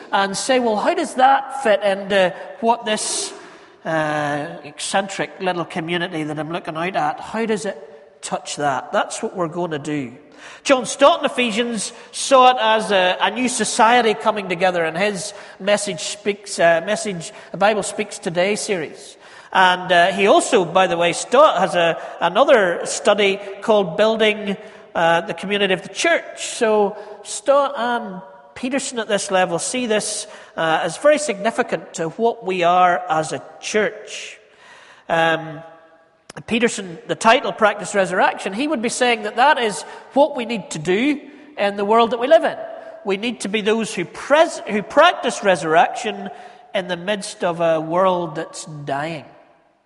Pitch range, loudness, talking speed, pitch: 175-235 Hz, -19 LUFS, 165 wpm, 205 Hz